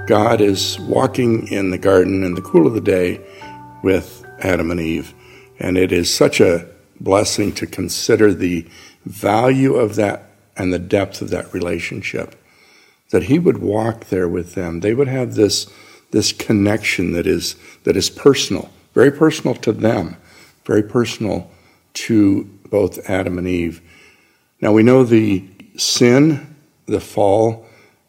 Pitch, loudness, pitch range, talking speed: 100 Hz, -17 LUFS, 90-115 Hz, 150 wpm